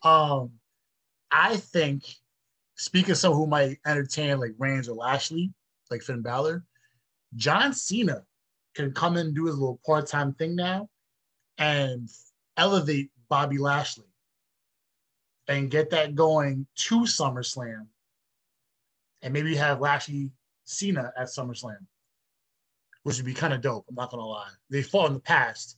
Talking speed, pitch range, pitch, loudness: 140 wpm, 125-155 Hz, 140 Hz, -26 LUFS